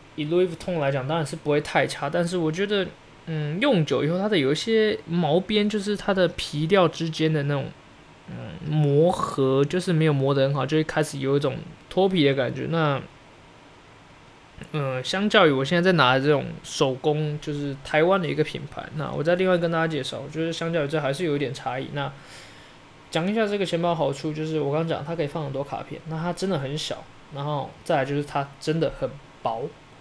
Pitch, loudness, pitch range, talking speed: 155 Hz, -24 LUFS, 140-170 Hz, 315 characters per minute